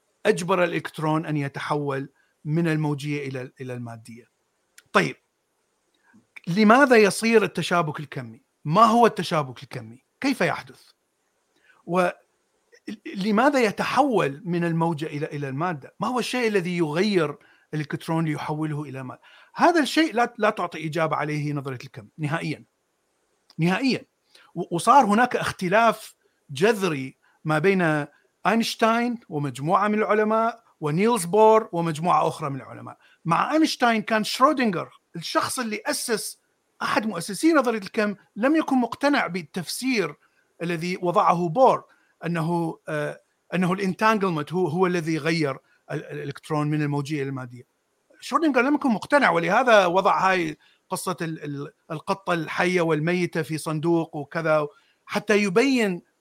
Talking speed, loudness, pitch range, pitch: 115 wpm, -23 LUFS, 150-220 Hz, 175 Hz